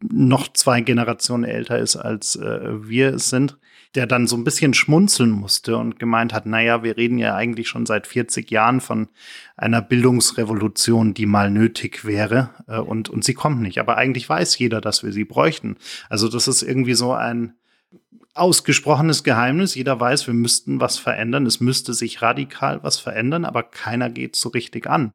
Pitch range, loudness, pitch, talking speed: 115-130 Hz, -19 LUFS, 120 Hz, 185 wpm